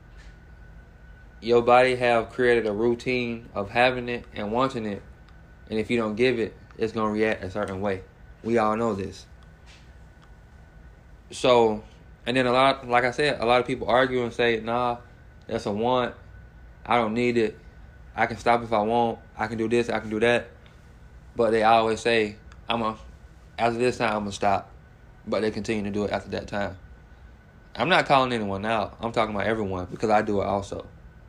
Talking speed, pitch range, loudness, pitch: 195 wpm, 95-120 Hz, -24 LUFS, 110 Hz